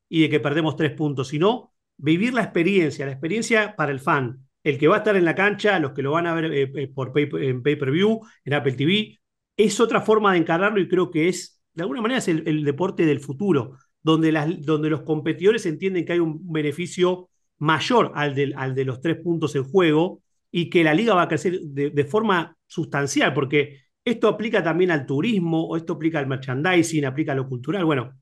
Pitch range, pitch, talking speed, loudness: 145-185 Hz, 160 Hz, 220 wpm, -22 LUFS